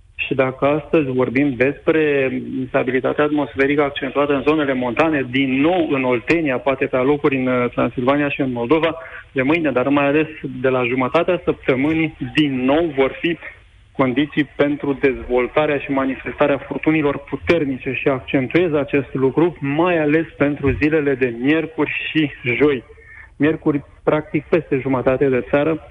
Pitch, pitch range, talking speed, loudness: 140 Hz, 130-155 Hz, 140 wpm, -18 LUFS